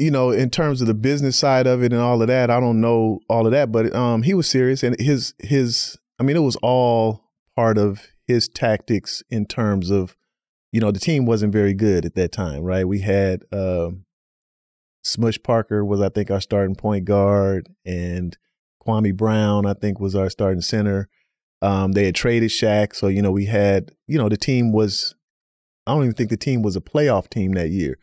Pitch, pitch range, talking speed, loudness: 105 Hz, 95-120 Hz, 210 wpm, -20 LUFS